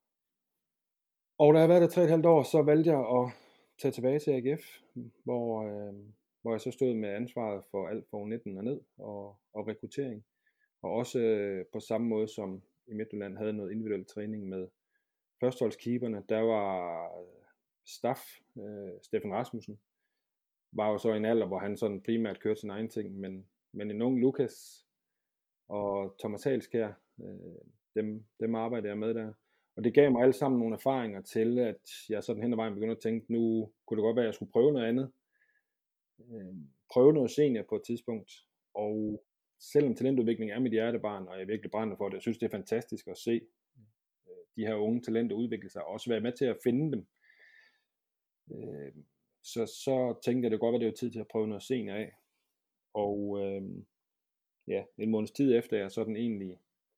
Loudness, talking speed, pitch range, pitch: -32 LUFS, 190 wpm, 105-120 Hz, 110 Hz